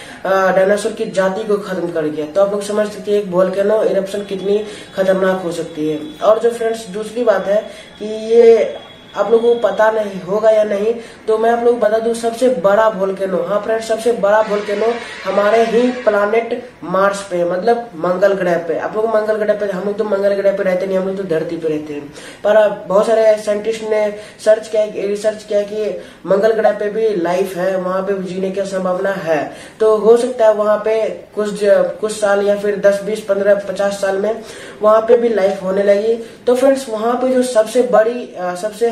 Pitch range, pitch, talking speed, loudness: 195-220 Hz, 210 Hz, 215 wpm, -15 LUFS